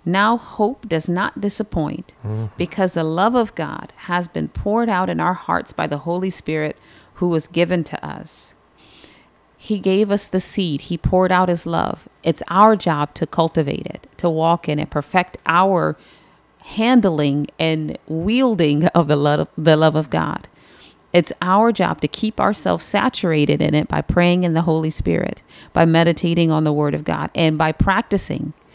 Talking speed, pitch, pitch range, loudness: 170 wpm, 170 Hz, 155-190 Hz, -19 LUFS